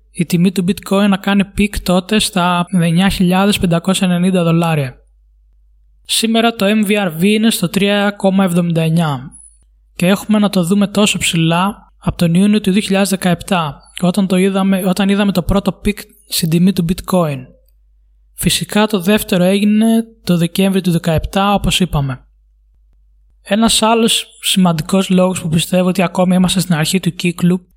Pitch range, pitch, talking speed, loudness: 170-200 Hz, 185 Hz, 140 wpm, -14 LUFS